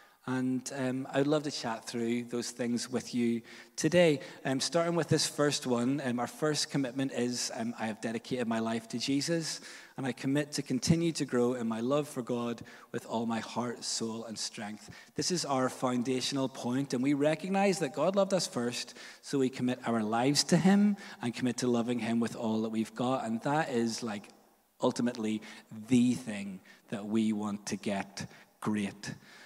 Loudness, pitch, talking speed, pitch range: -32 LUFS, 125 Hz, 190 wpm, 115-145 Hz